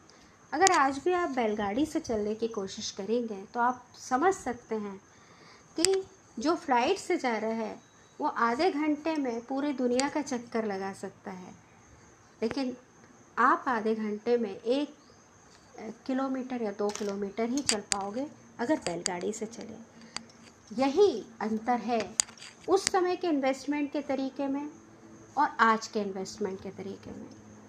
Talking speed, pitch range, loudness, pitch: 145 wpm, 215-290 Hz, -30 LUFS, 245 Hz